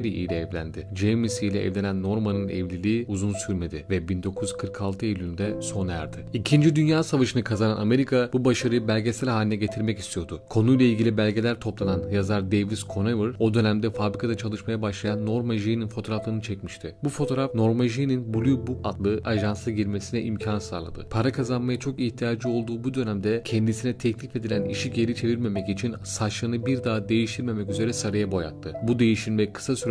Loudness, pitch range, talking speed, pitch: -26 LUFS, 100-120 Hz, 155 wpm, 110 Hz